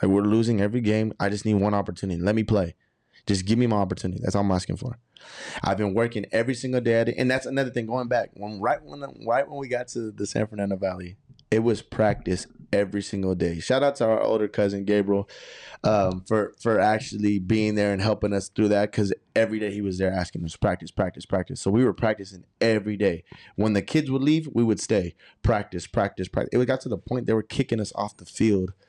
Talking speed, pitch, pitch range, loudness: 235 wpm, 105 Hz, 100-115 Hz, -25 LUFS